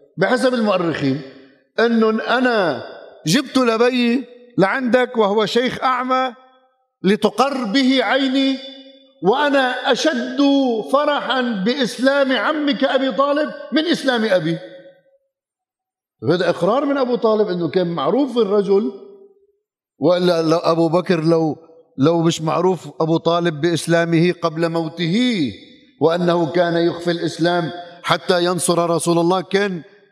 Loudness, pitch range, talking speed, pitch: -18 LUFS, 170-265 Hz, 105 wpm, 220 Hz